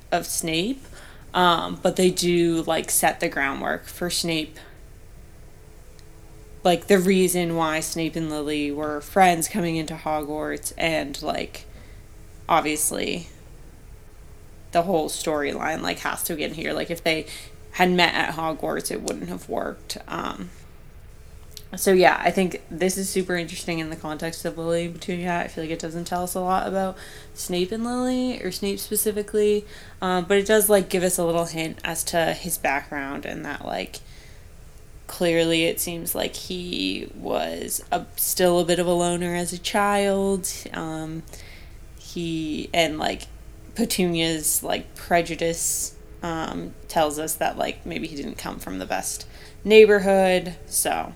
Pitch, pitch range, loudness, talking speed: 170 Hz, 155-185 Hz, -23 LUFS, 155 wpm